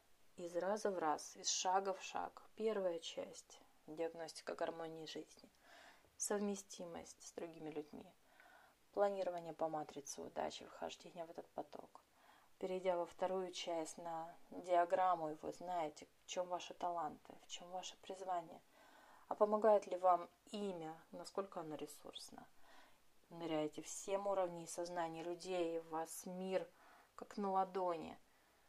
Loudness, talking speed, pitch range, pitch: -43 LUFS, 130 wpm, 165-190 Hz, 175 Hz